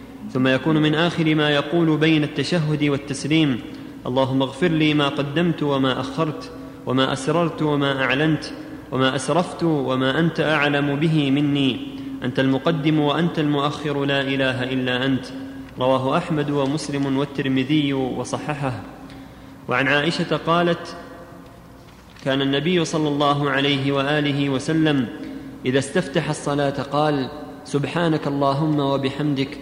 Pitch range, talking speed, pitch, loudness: 135-155 Hz, 115 wpm, 145 Hz, -21 LUFS